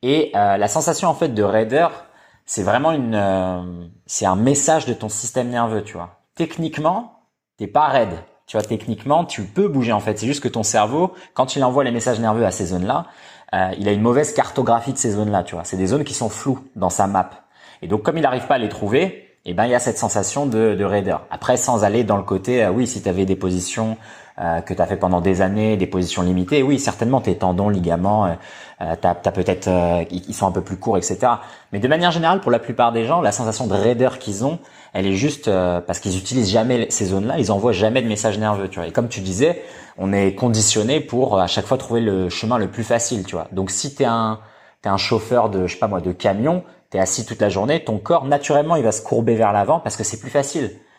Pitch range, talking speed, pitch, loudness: 95-125 Hz, 250 wpm, 110 Hz, -19 LUFS